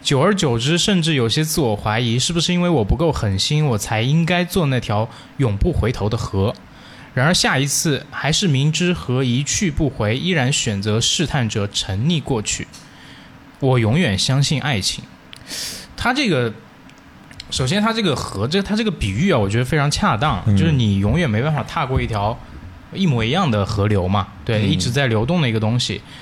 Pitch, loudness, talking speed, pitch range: 125 Hz, -18 LUFS, 275 characters per minute, 105-155 Hz